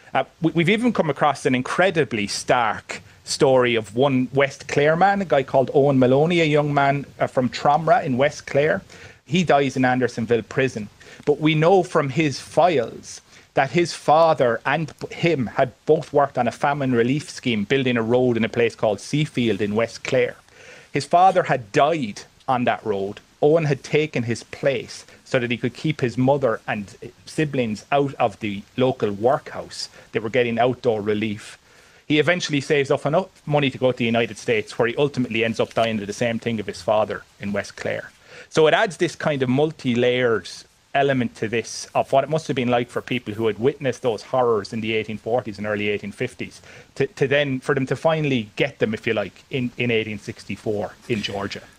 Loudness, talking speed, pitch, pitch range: -21 LUFS, 195 wpm, 130 Hz, 115-145 Hz